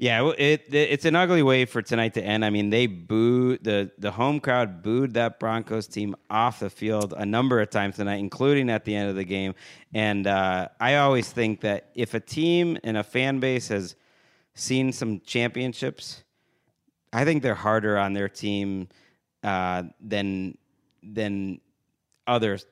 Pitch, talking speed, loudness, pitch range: 110 Hz, 175 wpm, -25 LUFS, 100-125 Hz